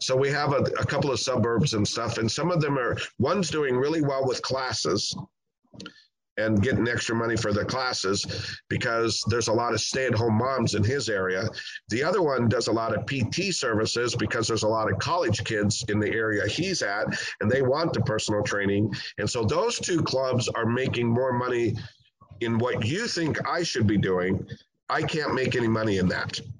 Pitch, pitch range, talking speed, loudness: 115 Hz, 105-130 Hz, 200 wpm, -26 LUFS